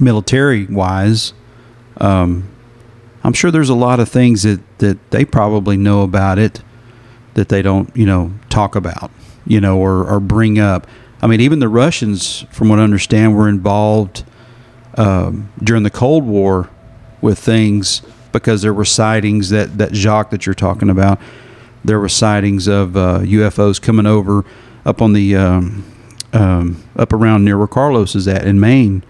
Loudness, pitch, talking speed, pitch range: -13 LUFS, 105 Hz, 165 wpm, 100-115 Hz